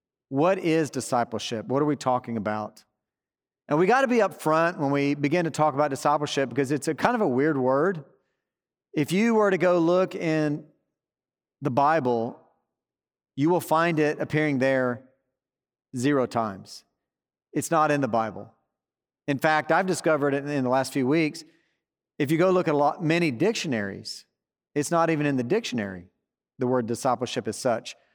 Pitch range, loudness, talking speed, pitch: 130-160 Hz, -25 LUFS, 175 wpm, 145 Hz